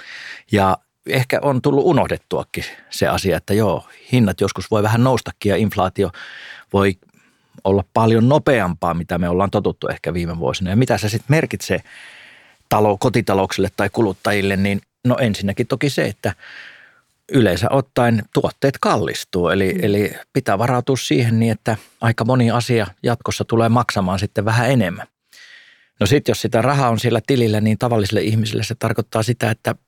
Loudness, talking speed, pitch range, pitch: -18 LUFS, 160 wpm, 100-125 Hz, 115 Hz